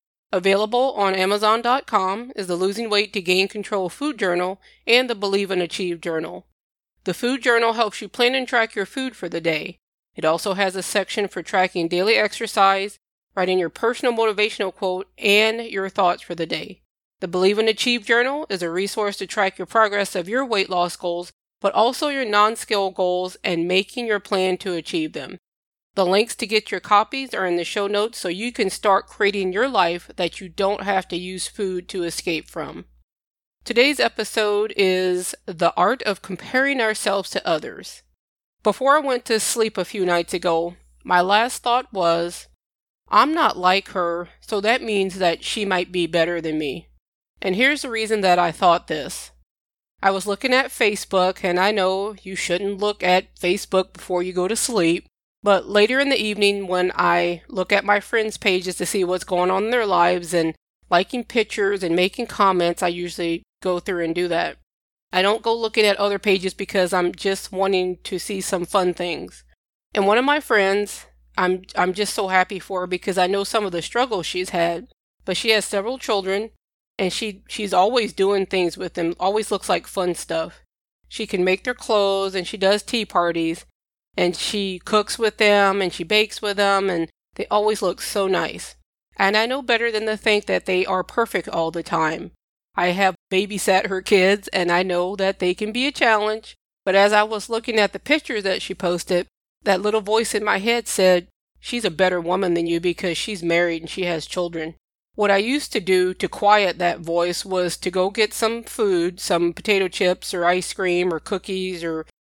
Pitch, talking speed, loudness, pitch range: 195 Hz, 195 wpm, -21 LUFS, 180-215 Hz